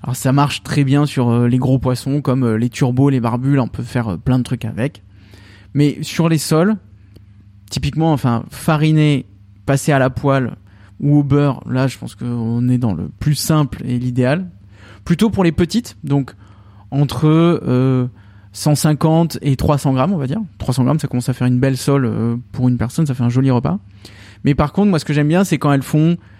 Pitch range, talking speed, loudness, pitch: 115-150 Hz, 210 wpm, -16 LUFS, 130 Hz